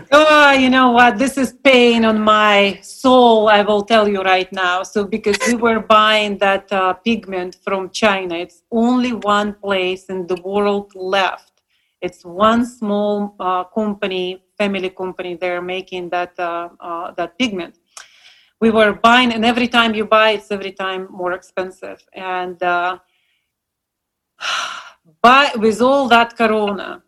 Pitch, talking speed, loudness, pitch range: 205 Hz, 150 wpm, -15 LUFS, 185-225 Hz